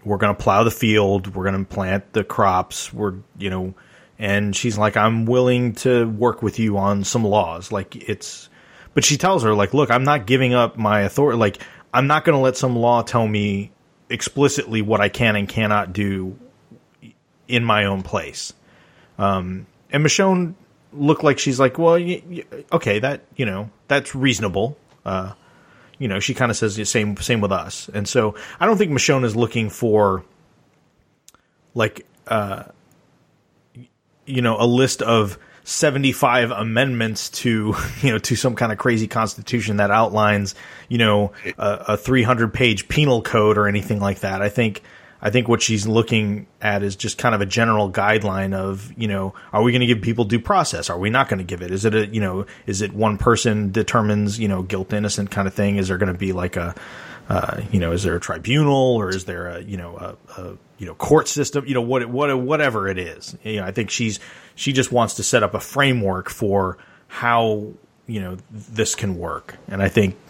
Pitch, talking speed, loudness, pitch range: 110 Hz, 205 wpm, -20 LUFS, 100-125 Hz